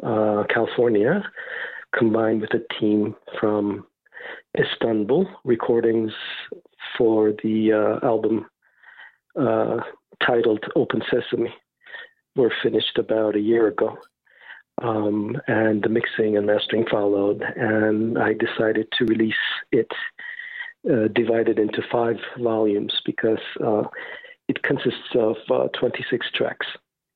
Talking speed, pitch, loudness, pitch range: 110 wpm, 110 Hz, -22 LUFS, 105-115 Hz